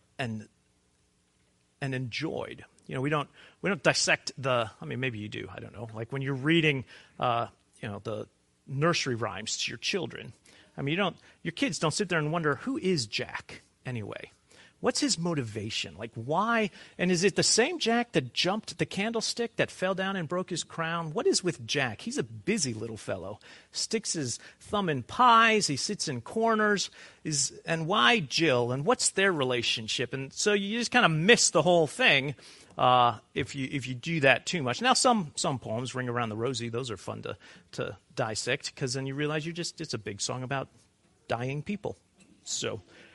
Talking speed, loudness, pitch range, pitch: 195 wpm, -28 LUFS, 120-185 Hz, 145 Hz